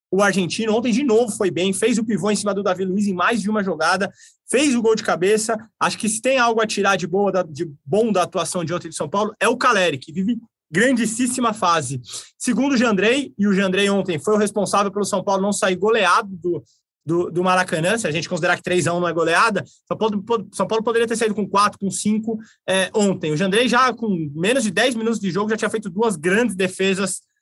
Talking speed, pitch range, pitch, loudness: 235 wpm, 185-225 Hz, 200 Hz, -20 LUFS